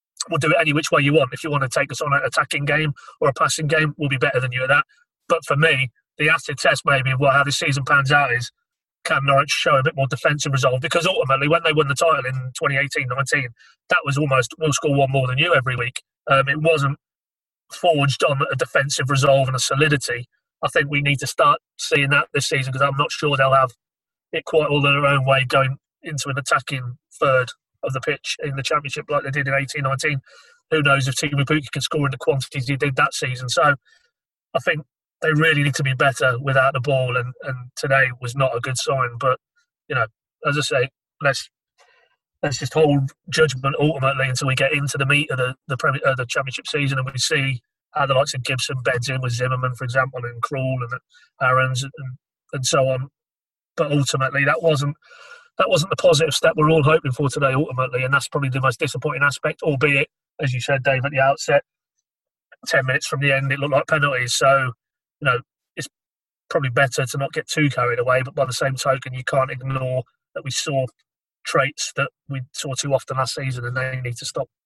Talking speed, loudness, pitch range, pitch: 225 wpm, -20 LUFS, 130-150 Hz, 140 Hz